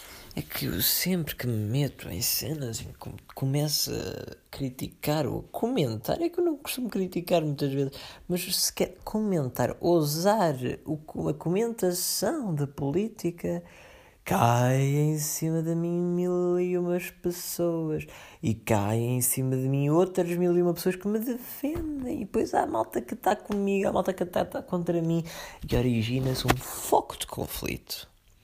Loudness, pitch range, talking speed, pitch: -28 LUFS, 130-180 Hz, 160 wpm, 165 Hz